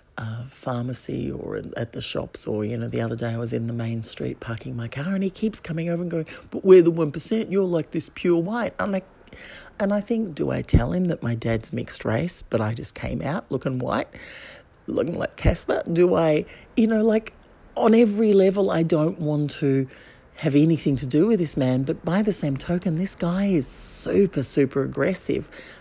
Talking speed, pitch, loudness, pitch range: 210 wpm, 160 Hz, -23 LUFS, 130-190 Hz